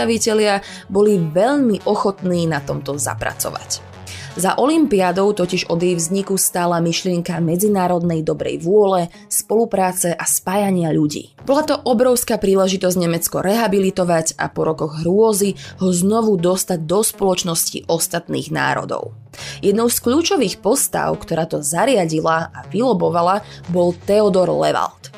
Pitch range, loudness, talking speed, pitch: 170-205 Hz, -17 LUFS, 120 wpm, 185 Hz